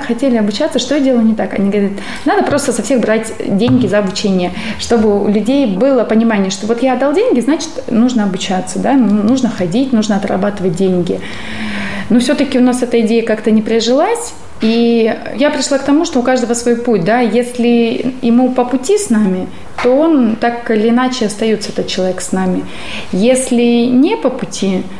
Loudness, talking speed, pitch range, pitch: -13 LUFS, 180 wpm, 210-255 Hz, 230 Hz